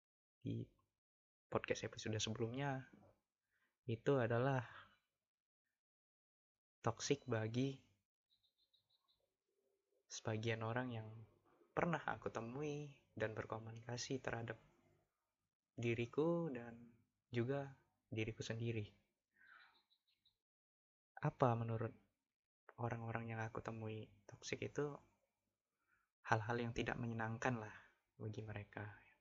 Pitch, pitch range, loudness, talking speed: 115 Hz, 110-125 Hz, -45 LUFS, 75 wpm